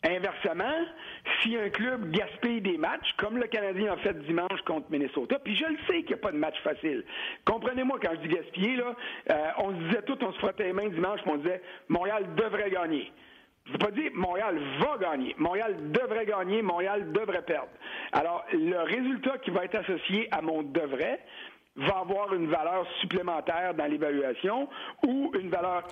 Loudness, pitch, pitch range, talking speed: -30 LUFS, 210 Hz, 185-255 Hz, 190 wpm